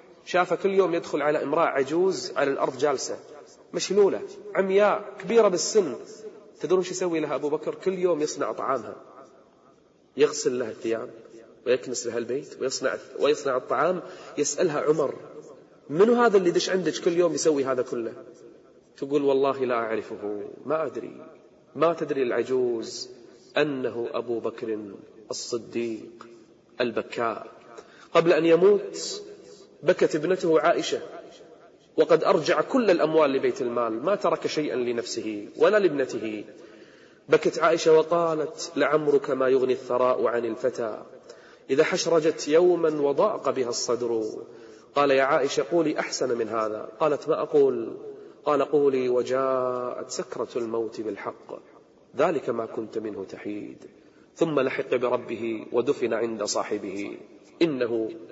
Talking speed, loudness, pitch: 125 wpm, -25 LUFS, 180 Hz